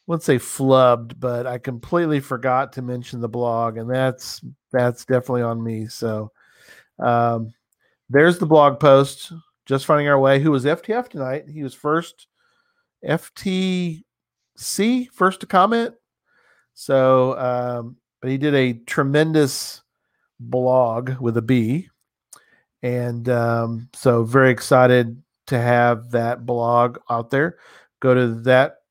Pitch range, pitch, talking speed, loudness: 120-150 Hz, 130 Hz, 135 wpm, -19 LUFS